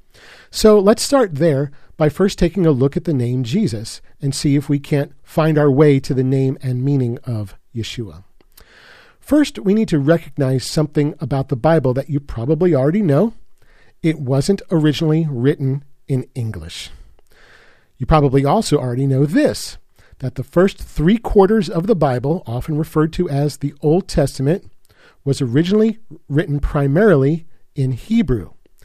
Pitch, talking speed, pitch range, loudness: 150 Hz, 155 wpm, 135-170 Hz, -17 LUFS